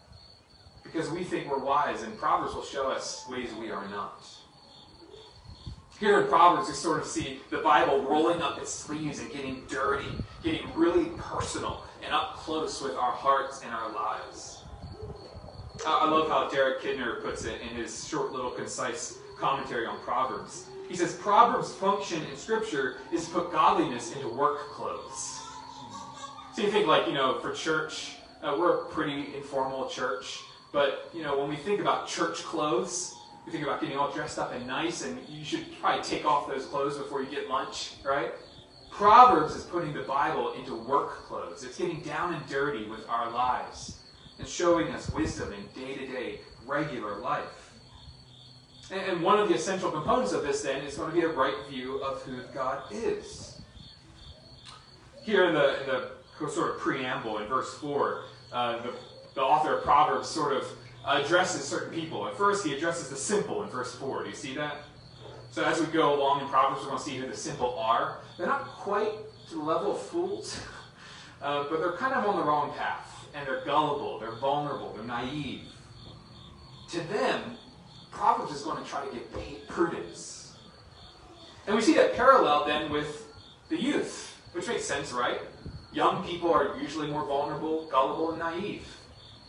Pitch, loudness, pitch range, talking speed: 150 Hz, -29 LUFS, 135-200 Hz, 180 wpm